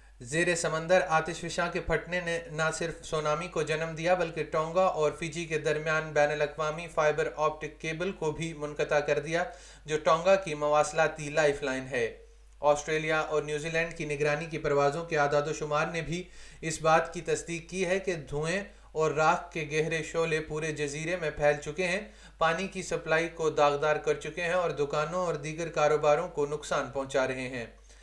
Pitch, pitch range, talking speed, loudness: 155 Hz, 150-170 Hz, 185 wpm, -29 LUFS